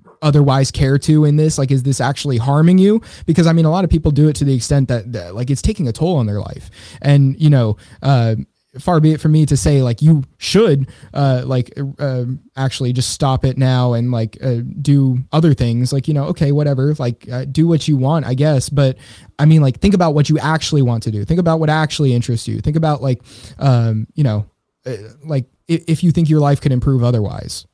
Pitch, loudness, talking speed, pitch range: 135 Hz, -15 LUFS, 235 wpm, 125-155 Hz